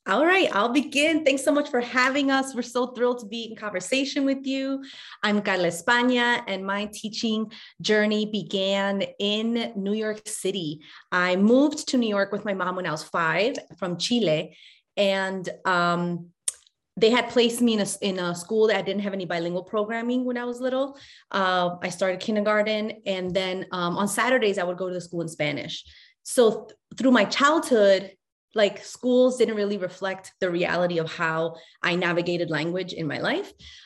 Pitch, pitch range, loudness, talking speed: 205 Hz, 185-240 Hz, -24 LUFS, 185 wpm